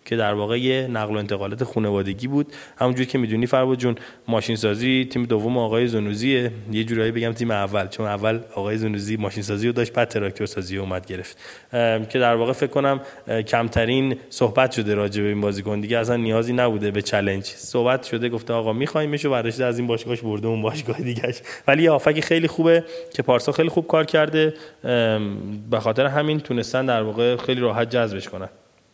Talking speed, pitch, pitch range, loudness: 185 wpm, 115 Hz, 105-130 Hz, -22 LUFS